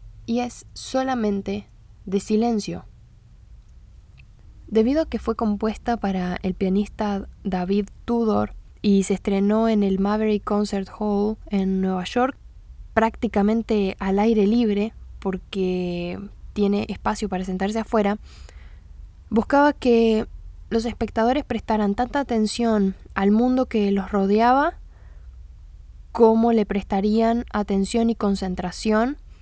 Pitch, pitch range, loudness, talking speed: 210 Hz, 195-225 Hz, -22 LUFS, 110 wpm